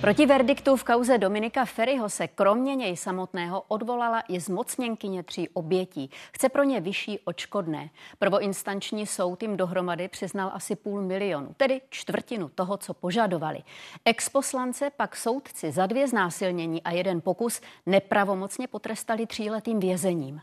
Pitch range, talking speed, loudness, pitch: 185-230 Hz, 135 wpm, -27 LUFS, 200 Hz